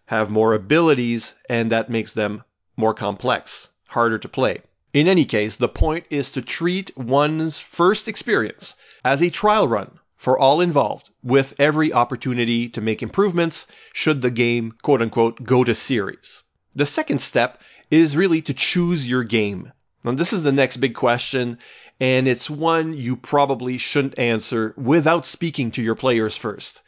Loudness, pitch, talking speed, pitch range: -20 LUFS, 130 Hz, 165 wpm, 115-155 Hz